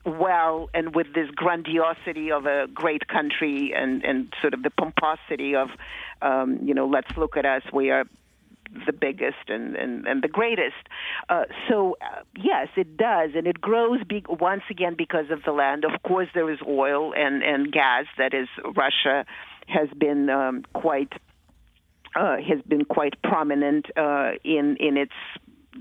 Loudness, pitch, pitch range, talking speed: -24 LUFS, 155 Hz, 140-175 Hz, 165 wpm